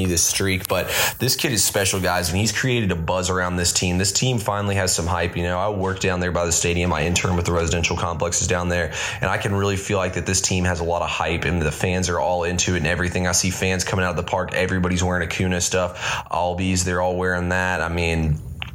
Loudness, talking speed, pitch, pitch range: -21 LUFS, 260 wpm, 90 Hz, 85-95 Hz